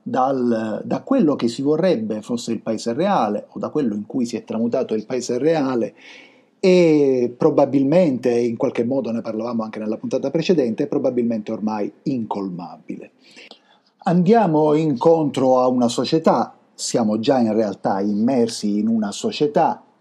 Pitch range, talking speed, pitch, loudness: 115-185 Hz, 145 wpm, 130 Hz, -20 LUFS